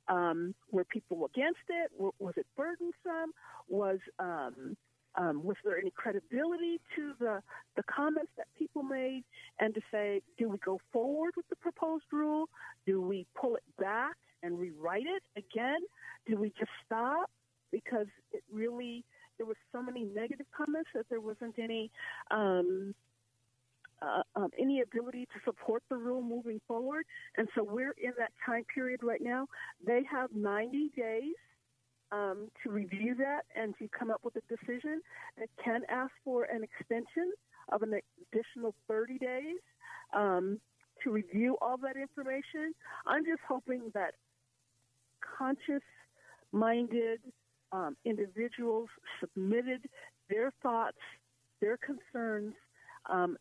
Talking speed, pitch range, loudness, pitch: 140 wpm, 210-285 Hz, -37 LUFS, 235 Hz